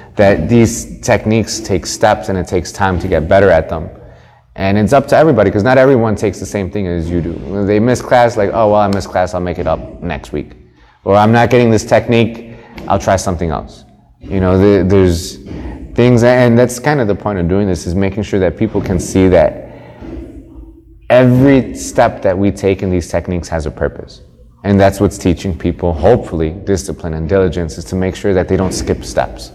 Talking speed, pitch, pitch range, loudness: 215 wpm, 95 Hz, 85-110 Hz, -13 LUFS